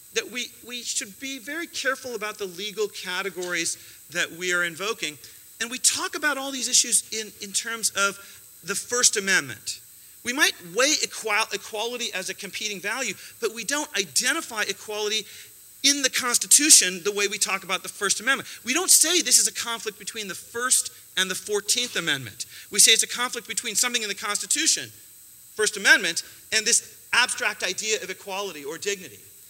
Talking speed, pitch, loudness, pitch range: 180 wpm, 215 Hz, -22 LUFS, 195-250 Hz